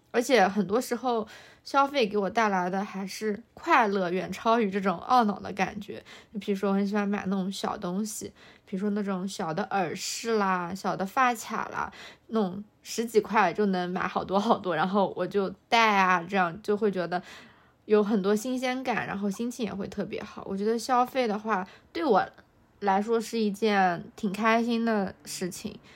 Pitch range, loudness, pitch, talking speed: 195-225 Hz, -27 LUFS, 205 Hz, 265 characters per minute